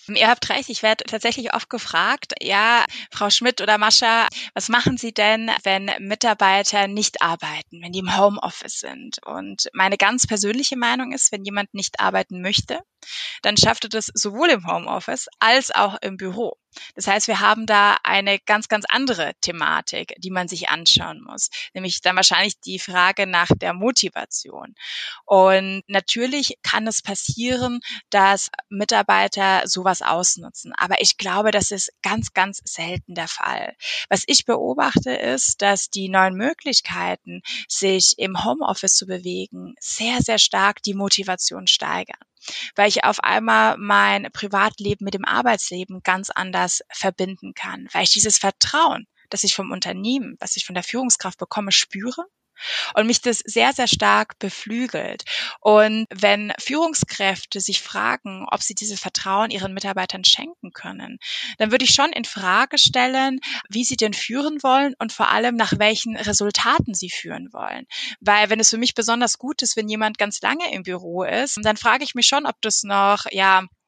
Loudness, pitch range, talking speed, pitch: -19 LUFS, 190-235 Hz, 165 wpm, 205 Hz